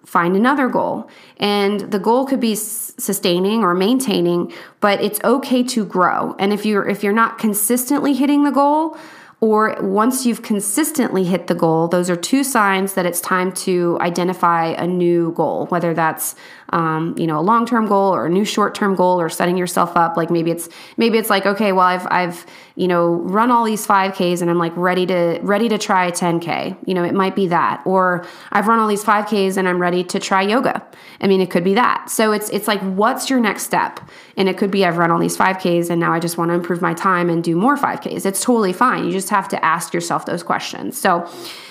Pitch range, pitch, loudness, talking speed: 175-220 Hz, 195 Hz, -17 LUFS, 225 wpm